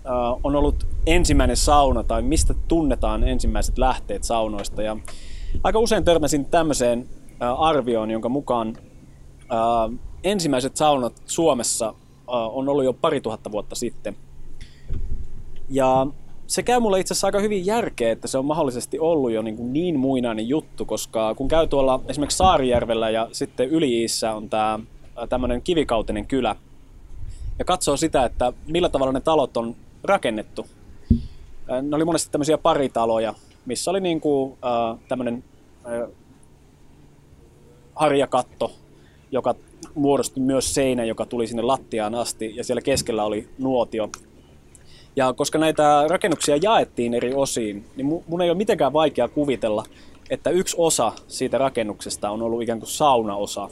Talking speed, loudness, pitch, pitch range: 135 wpm, -22 LUFS, 125 Hz, 110-145 Hz